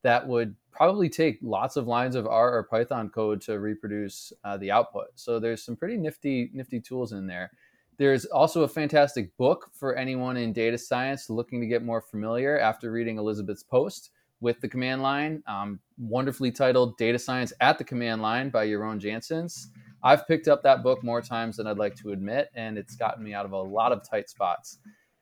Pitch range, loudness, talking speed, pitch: 110-130 Hz, -27 LUFS, 200 wpm, 120 Hz